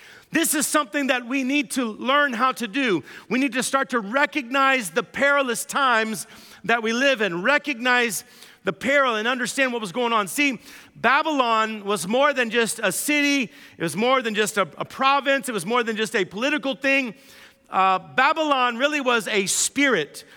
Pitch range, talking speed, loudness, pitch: 220-280 Hz, 185 wpm, -21 LUFS, 250 Hz